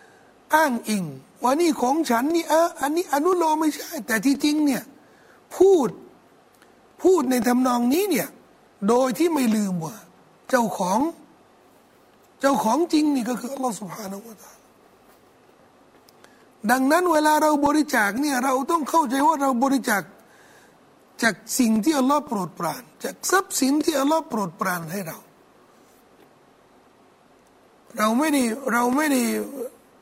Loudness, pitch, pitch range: -22 LUFS, 270 Hz, 225-310 Hz